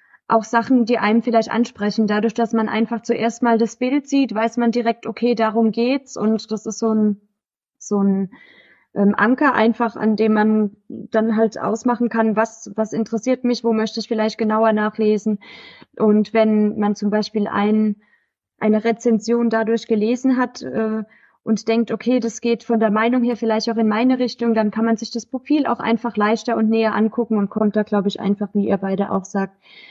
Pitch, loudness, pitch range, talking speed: 225 Hz, -19 LUFS, 215-235 Hz, 195 wpm